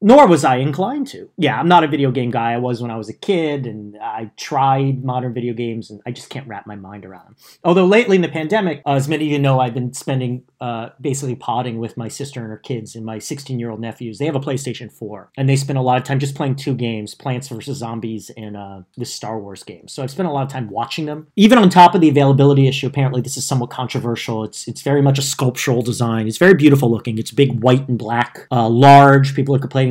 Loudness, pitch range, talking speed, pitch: -16 LUFS, 115-140 Hz, 255 wpm, 130 Hz